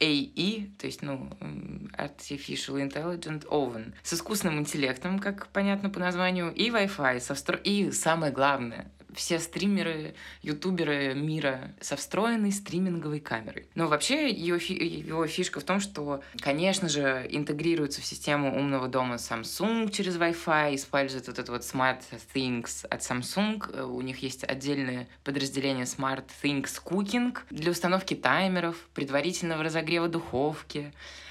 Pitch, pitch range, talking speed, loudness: 150 Hz, 135-180 Hz, 135 wpm, -30 LUFS